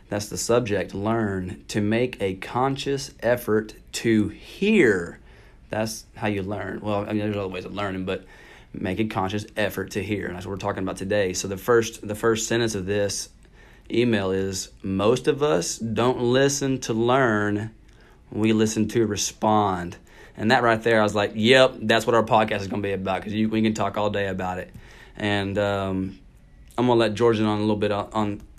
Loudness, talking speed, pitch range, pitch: -23 LUFS, 205 wpm, 100-115 Hz, 105 Hz